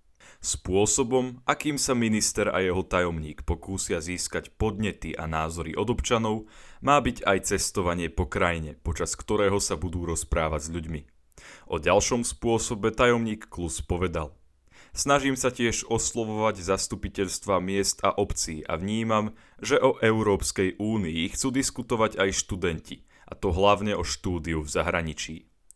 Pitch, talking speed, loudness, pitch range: 100 Hz, 135 wpm, -26 LUFS, 85-110 Hz